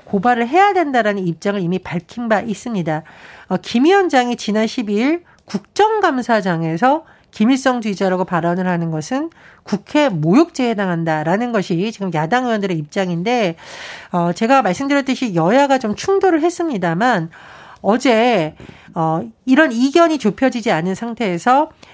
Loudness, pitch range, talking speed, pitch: -17 LUFS, 180-260 Hz, 320 characters per minute, 220 Hz